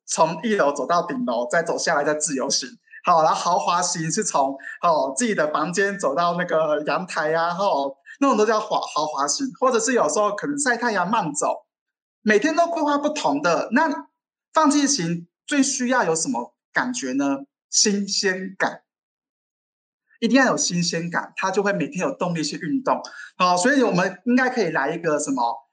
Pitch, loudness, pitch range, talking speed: 190 Hz, -21 LUFS, 160-250 Hz, 270 characters per minute